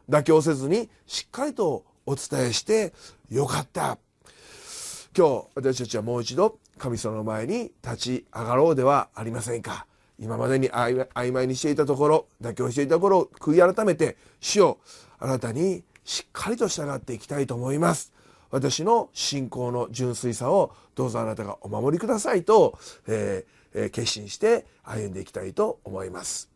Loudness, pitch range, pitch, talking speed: -25 LUFS, 120-160 Hz, 130 Hz, 320 characters per minute